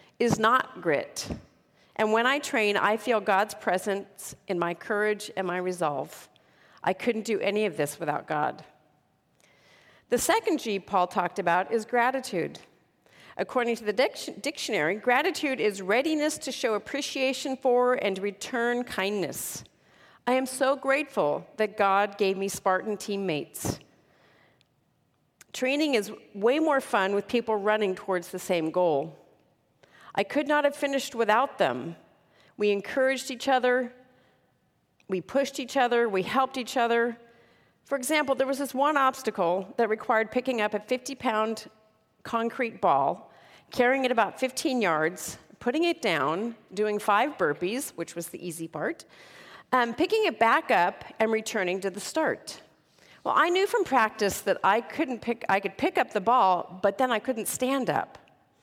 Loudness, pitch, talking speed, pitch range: -27 LUFS, 225 Hz, 155 wpm, 195-260 Hz